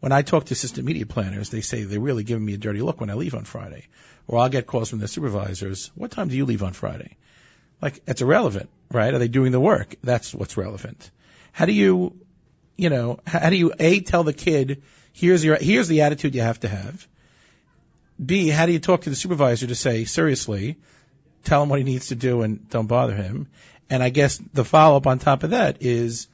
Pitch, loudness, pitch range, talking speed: 130 Hz, -21 LUFS, 115-155 Hz, 230 wpm